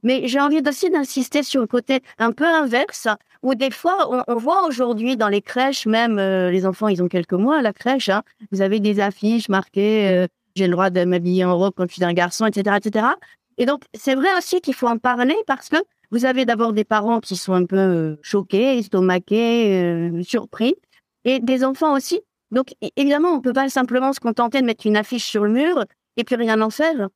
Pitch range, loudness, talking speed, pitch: 200-265 Hz, -19 LUFS, 225 wpm, 235 Hz